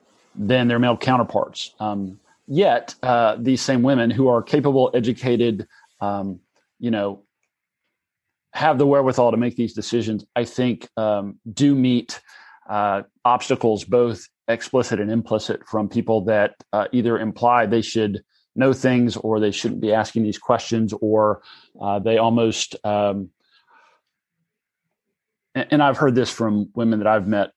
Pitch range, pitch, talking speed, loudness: 105-125 Hz, 115 Hz, 145 wpm, -20 LUFS